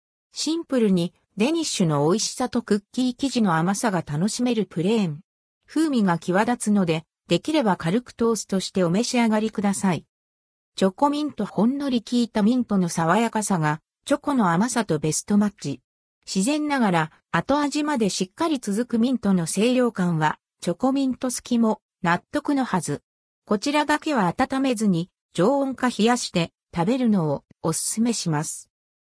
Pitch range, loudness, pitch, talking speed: 175-250 Hz, -23 LUFS, 215 Hz, 340 characters per minute